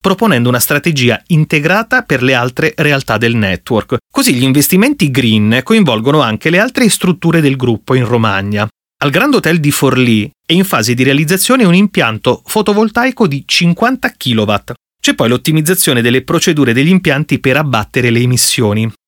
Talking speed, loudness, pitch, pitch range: 155 wpm, -11 LUFS, 145 Hz, 120-180 Hz